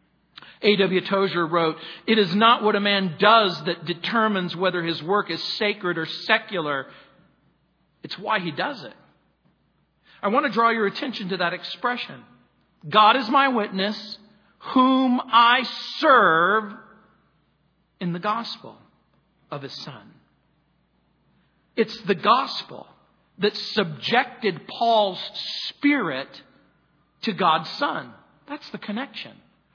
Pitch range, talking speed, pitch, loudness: 185-235 Hz, 120 wpm, 210 Hz, -22 LUFS